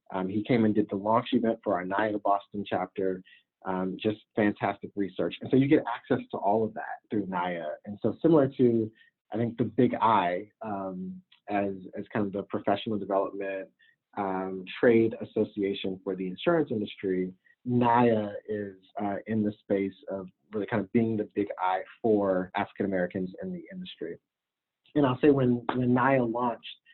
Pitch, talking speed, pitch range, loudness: 105 Hz, 175 wpm, 95-120 Hz, -28 LUFS